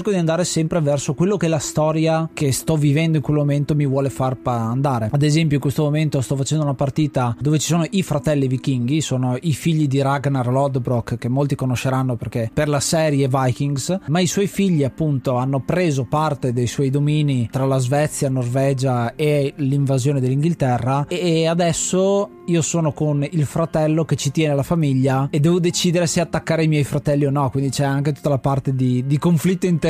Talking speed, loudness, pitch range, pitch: 195 wpm, -19 LUFS, 135-160 Hz, 145 Hz